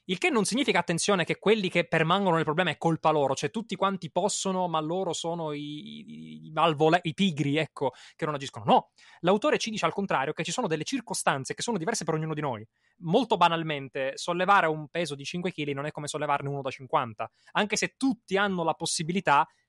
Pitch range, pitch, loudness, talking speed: 150-190 Hz, 165 Hz, -27 LUFS, 215 wpm